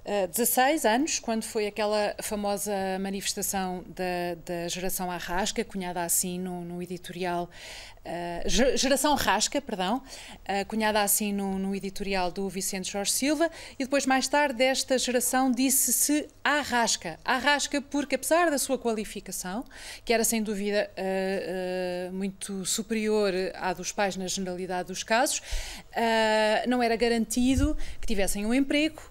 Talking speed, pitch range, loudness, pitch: 130 wpm, 190-255 Hz, -27 LUFS, 210 Hz